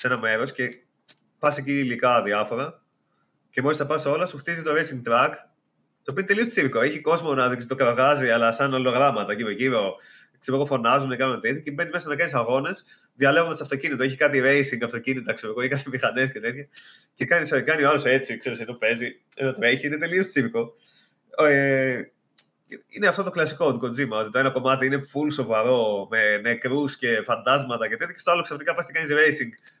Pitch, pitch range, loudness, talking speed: 135 Hz, 125-150 Hz, -23 LUFS, 200 wpm